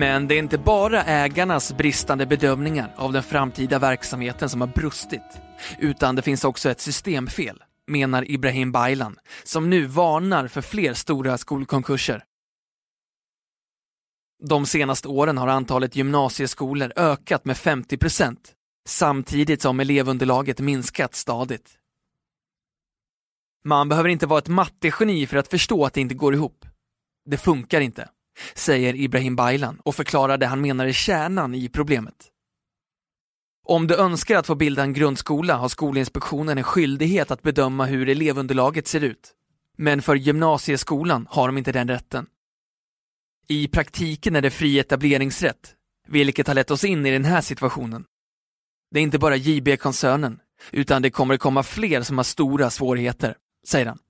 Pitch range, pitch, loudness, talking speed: 135-150 Hz, 140 Hz, -21 LUFS, 145 wpm